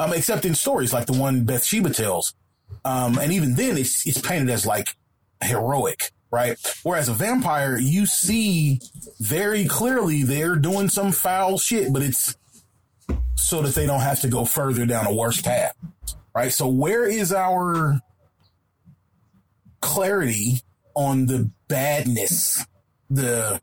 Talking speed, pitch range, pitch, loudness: 140 wpm, 120-175 Hz, 135 Hz, -21 LUFS